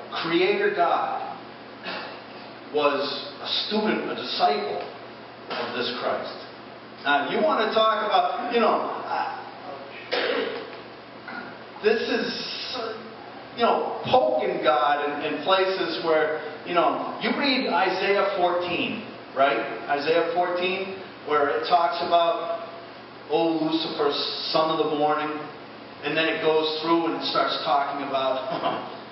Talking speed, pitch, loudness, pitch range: 120 wpm, 165 Hz, -24 LUFS, 150-210 Hz